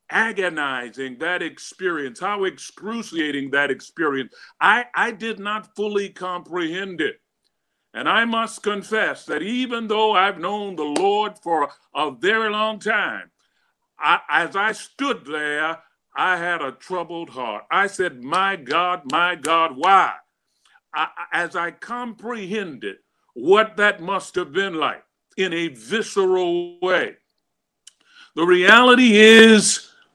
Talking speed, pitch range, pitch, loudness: 125 wpm, 175-225 Hz, 200 Hz, -20 LUFS